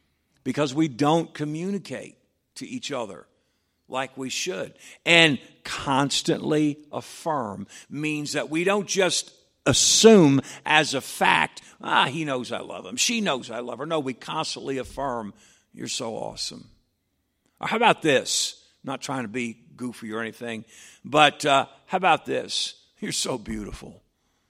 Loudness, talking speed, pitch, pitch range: -23 LUFS, 145 wpm, 150 Hz, 130-165 Hz